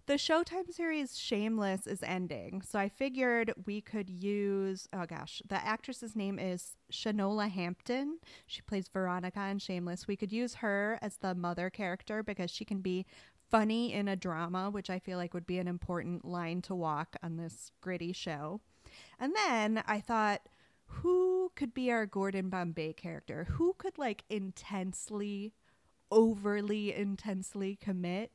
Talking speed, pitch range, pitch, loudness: 155 wpm, 185-220 Hz, 200 Hz, -36 LUFS